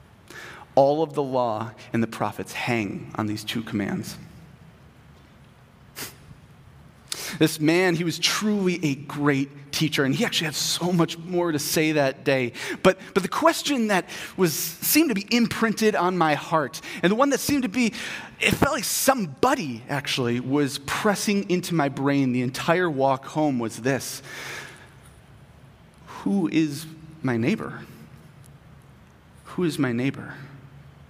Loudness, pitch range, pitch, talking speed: -24 LUFS, 135-180 Hz, 155 Hz, 145 wpm